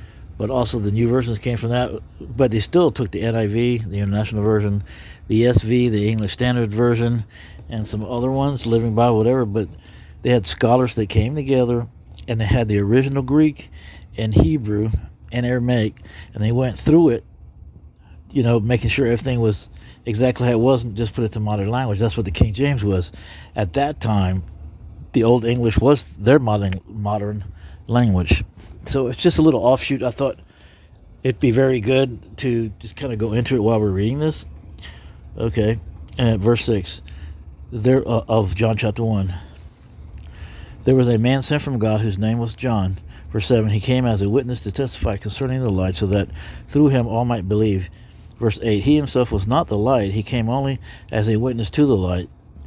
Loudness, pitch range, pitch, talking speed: -19 LUFS, 100-125 Hz, 110 Hz, 190 wpm